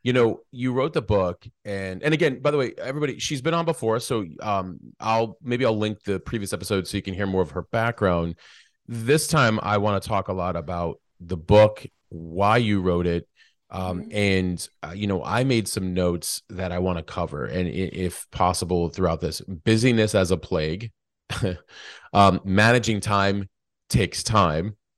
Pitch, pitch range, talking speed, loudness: 100 Hz, 90-115 Hz, 185 wpm, -24 LUFS